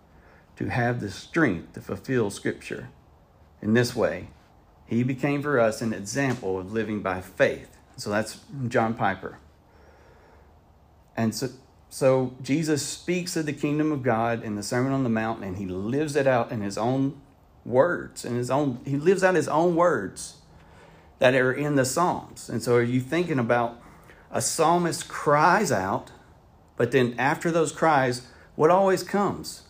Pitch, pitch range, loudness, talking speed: 130 Hz, 115-150 Hz, -25 LUFS, 165 wpm